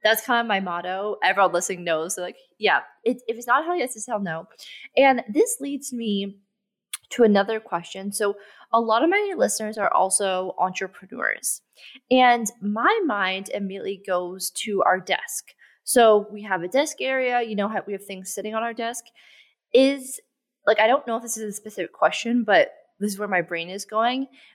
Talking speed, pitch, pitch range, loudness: 195 wpm, 215 Hz, 195-245 Hz, -23 LUFS